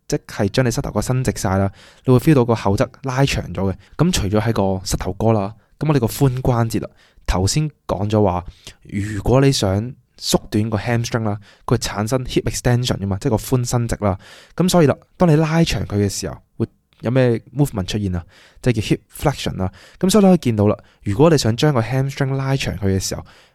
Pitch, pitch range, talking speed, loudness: 115 Hz, 100-135 Hz, 400 characters per minute, -19 LUFS